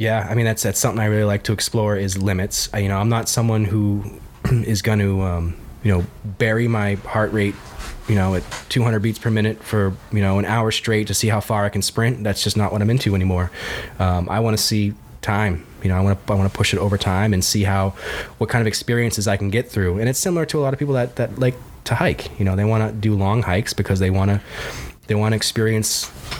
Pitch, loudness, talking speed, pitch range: 105 Hz, -20 LUFS, 260 wpm, 100-110 Hz